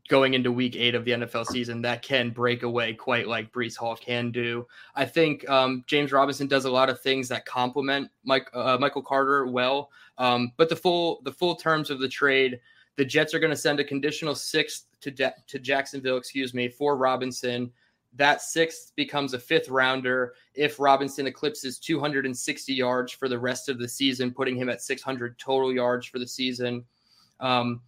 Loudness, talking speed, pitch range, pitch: -26 LUFS, 200 wpm, 125-140 Hz, 130 Hz